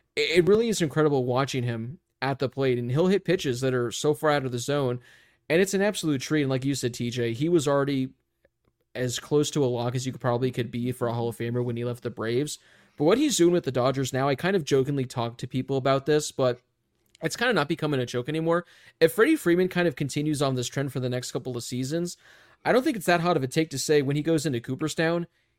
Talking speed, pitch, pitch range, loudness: 265 wpm, 135 Hz, 125-160 Hz, -26 LUFS